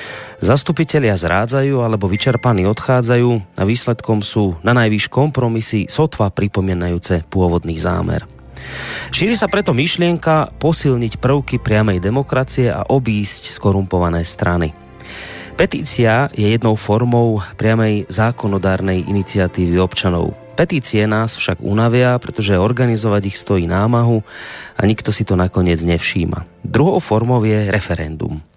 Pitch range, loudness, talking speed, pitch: 95-125 Hz, -16 LUFS, 115 wpm, 110 Hz